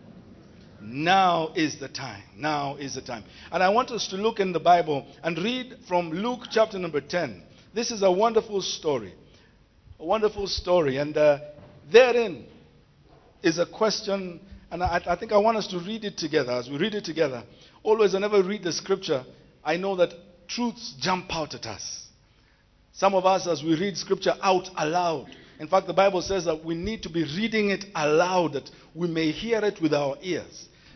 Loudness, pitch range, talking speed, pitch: -25 LUFS, 155-200 Hz, 190 wpm, 175 Hz